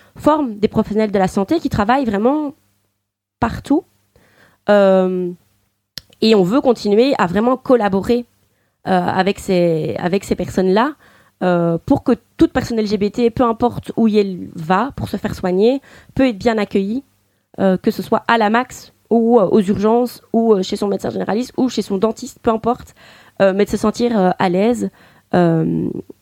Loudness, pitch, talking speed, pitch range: -17 LUFS, 215 Hz, 170 wpm, 190-240 Hz